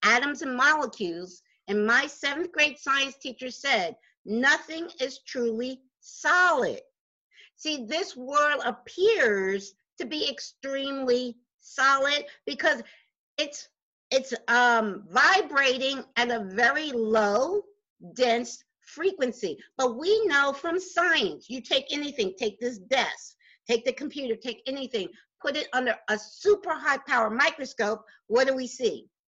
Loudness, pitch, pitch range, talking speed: -26 LUFS, 270 Hz, 240-310 Hz, 125 wpm